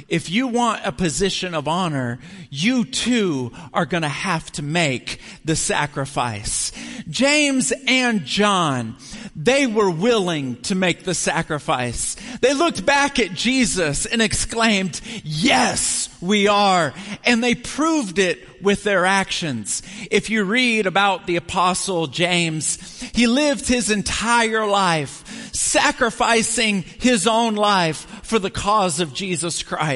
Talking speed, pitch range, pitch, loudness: 130 wpm, 170-230 Hz, 195 Hz, -19 LUFS